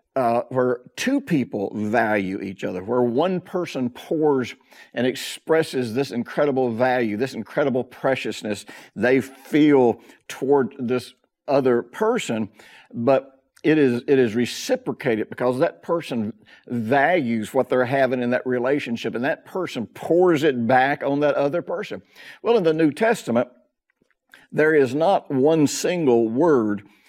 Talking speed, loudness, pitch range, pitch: 135 wpm, -22 LUFS, 120-145 Hz, 130 Hz